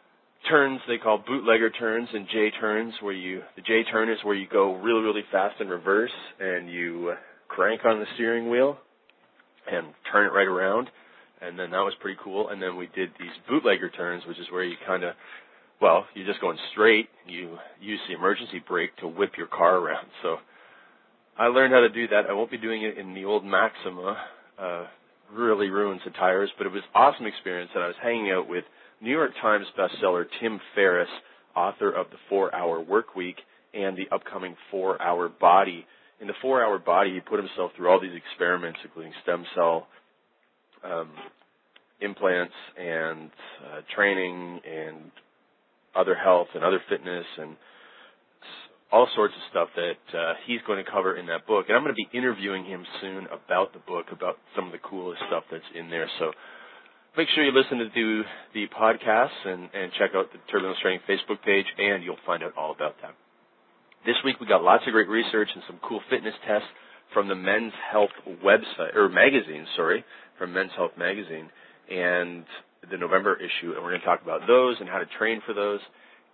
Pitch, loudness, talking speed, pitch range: 100 Hz, -25 LUFS, 190 wpm, 90-110 Hz